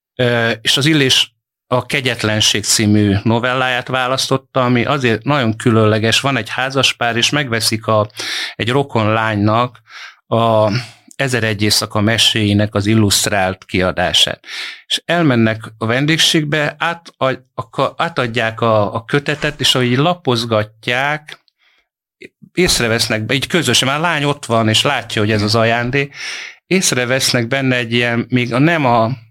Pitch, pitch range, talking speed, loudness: 120 Hz, 110-135 Hz, 135 wpm, -15 LUFS